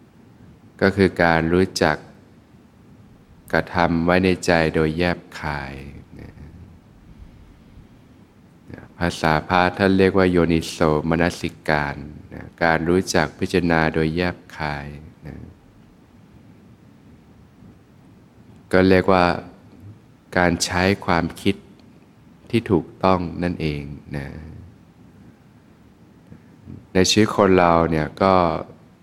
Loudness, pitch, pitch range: -20 LUFS, 85 Hz, 80-95 Hz